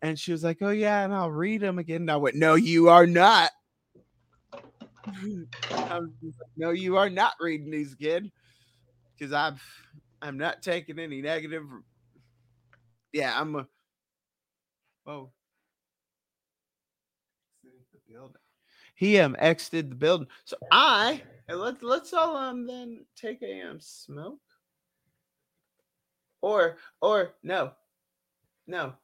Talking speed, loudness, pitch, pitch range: 125 wpm, -25 LUFS, 165 Hz, 145-195 Hz